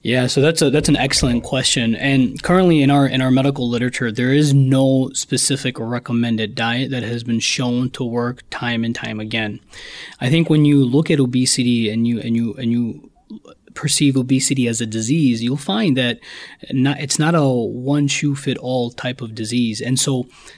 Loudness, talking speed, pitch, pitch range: -17 LUFS, 190 wpm, 130 Hz, 120-140 Hz